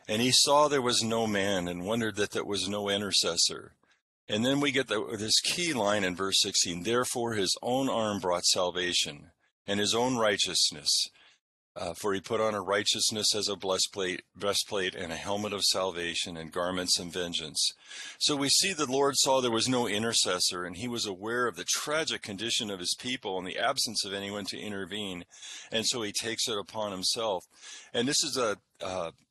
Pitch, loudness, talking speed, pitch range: 105 Hz, -28 LUFS, 195 wpm, 95-120 Hz